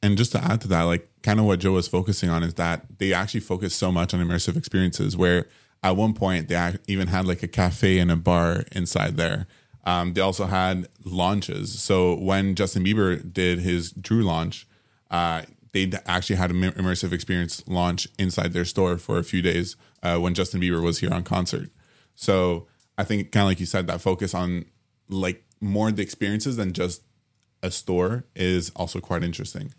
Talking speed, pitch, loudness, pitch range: 200 wpm, 95 Hz, -24 LUFS, 90-100 Hz